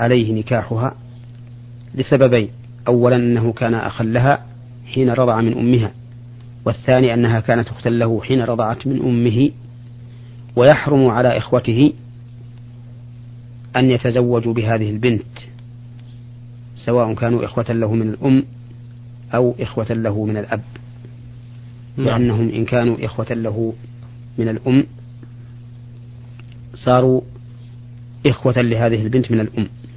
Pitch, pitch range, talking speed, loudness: 120 Hz, 115-120 Hz, 105 wpm, -17 LUFS